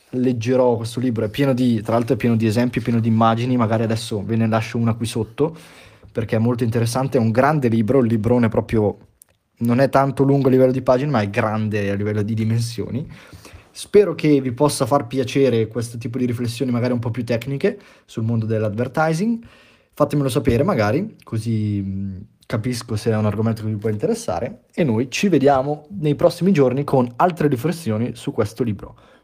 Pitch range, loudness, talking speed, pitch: 110-135 Hz, -20 LUFS, 190 wpm, 120 Hz